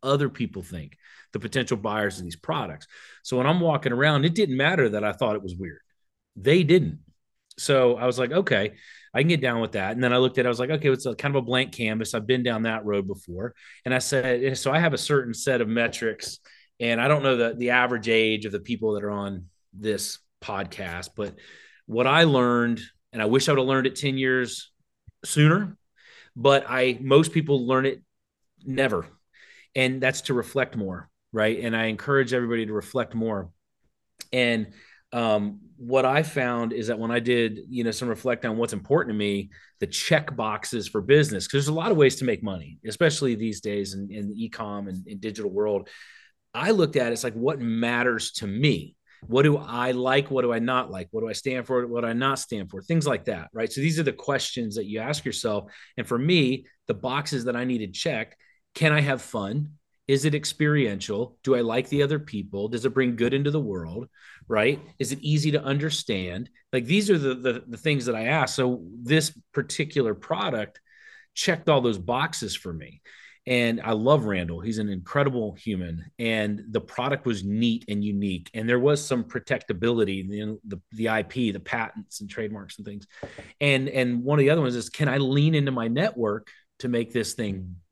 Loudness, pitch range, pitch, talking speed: -25 LUFS, 110-135 Hz, 125 Hz, 215 wpm